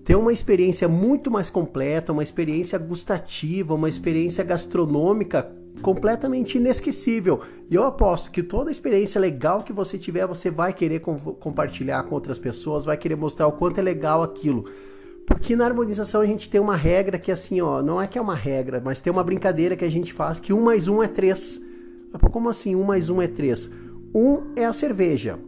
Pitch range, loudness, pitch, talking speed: 160-210 Hz, -23 LUFS, 185 Hz, 205 wpm